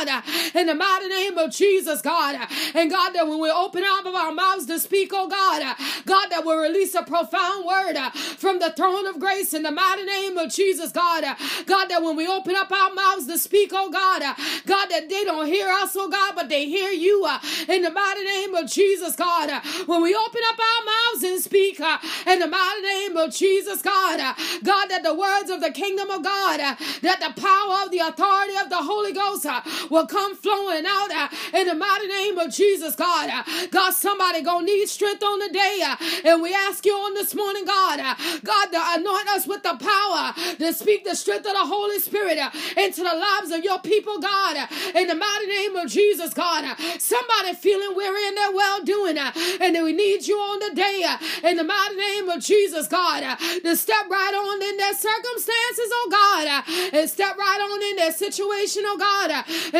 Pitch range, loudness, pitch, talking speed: 335-395 Hz, -21 LUFS, 375 Hz, 215 wpm